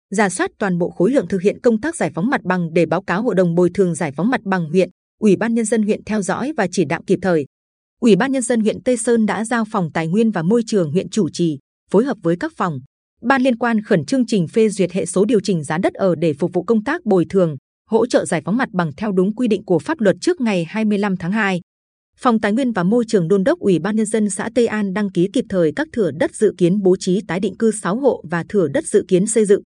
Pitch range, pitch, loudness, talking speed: 180-225 Hz, 200 Hz, -18 LUFS, 280 wpm